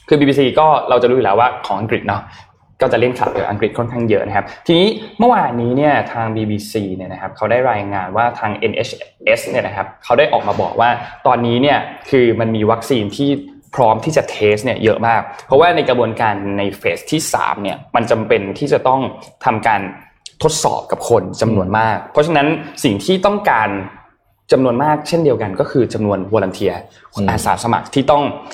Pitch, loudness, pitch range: 120 Hz, -15 LUFS, 105-145 Hz